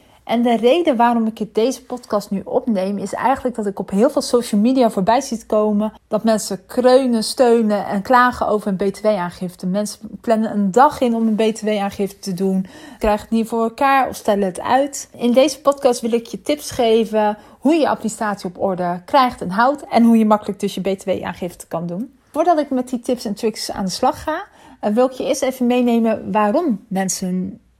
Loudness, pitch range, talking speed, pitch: -18 LUFS, 205-250 Hz, 200 wpm, 225 Hz